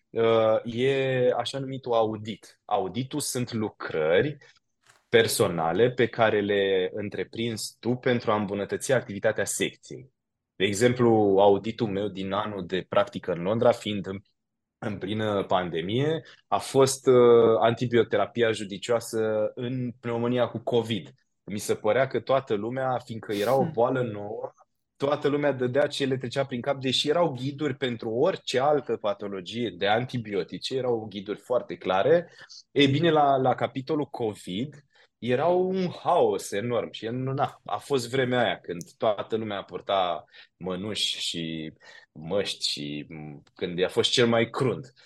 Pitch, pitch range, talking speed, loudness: 120 Hz, 105-130 Hz, 135 wpm, -26 LUFS